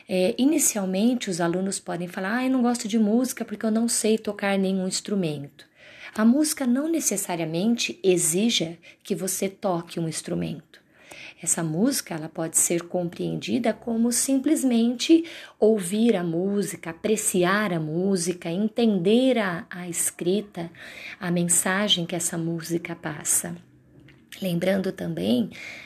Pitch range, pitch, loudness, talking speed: 175-230 Hz, 195 Hz, -24 LUFS, 130 wpm